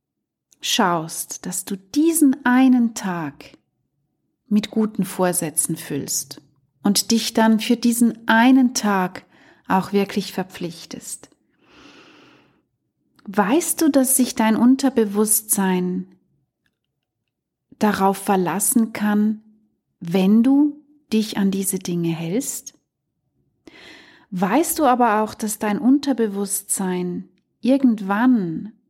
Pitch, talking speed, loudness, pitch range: 215 Hz, 90 wpm, -19 LUFS, 195-255 Hz